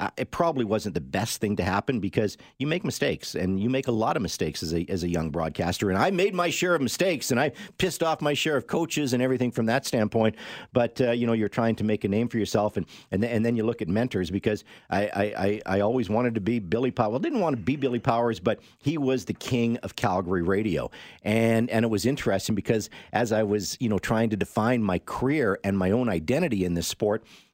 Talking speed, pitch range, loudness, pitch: 250 wpm, 100-125 Hz, -26 LUFS, 115 Hz